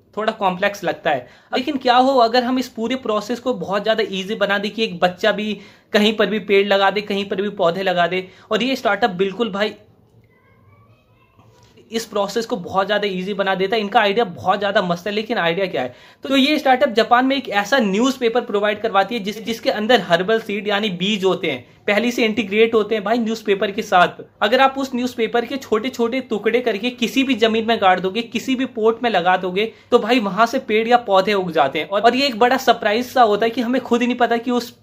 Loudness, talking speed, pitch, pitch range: -18 LUFS, 165 wpm, 220 Hz, 200-240 Hz